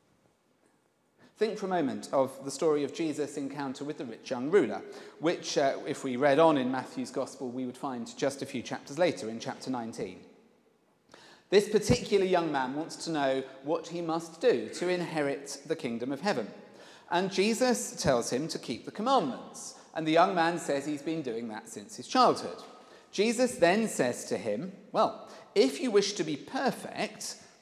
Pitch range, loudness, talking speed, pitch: 135-205 Hz, -30 LUFS, 185 wpm, 160 Hz